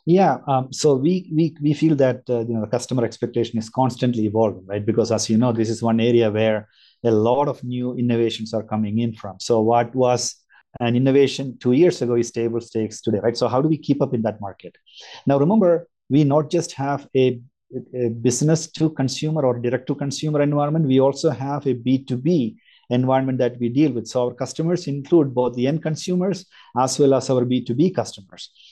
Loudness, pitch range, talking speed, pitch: -20 LUFS, 115-145 Hz, 205 wpm, 125 Hz